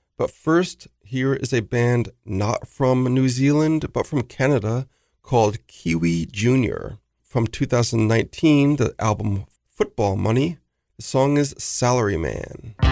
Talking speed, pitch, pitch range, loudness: 125 wpm, 125 Hz, 105-135 Hz, -21 LUFS